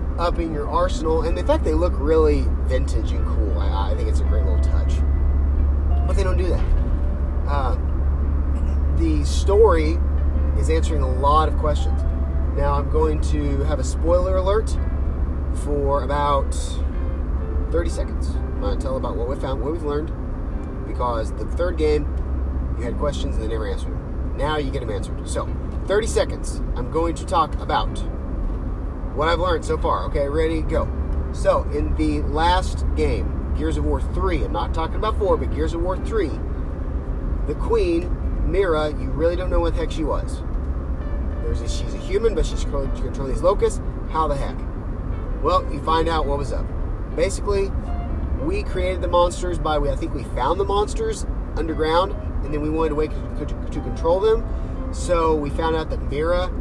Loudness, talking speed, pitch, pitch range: -23 LUFS, 180 wpm, 70 Hz, 65-75 Hz